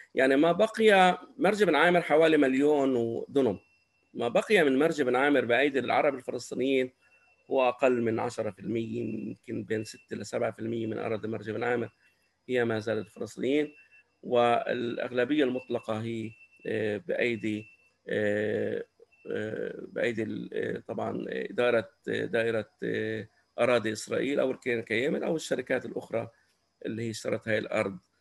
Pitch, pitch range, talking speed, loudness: 120 Hz, 110-135 Hz, 120 wpm, -29 LUFS